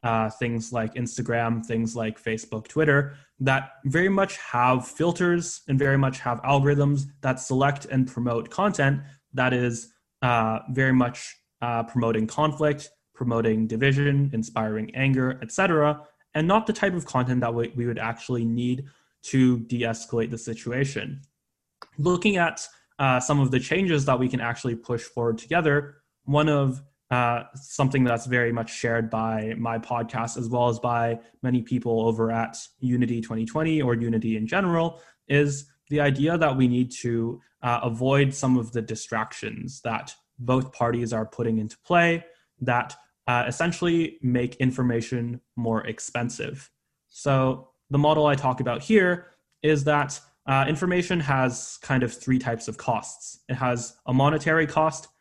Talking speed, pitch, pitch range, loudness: 155 wpm, 130 Hz, 120-145 Hz, -25 LUFS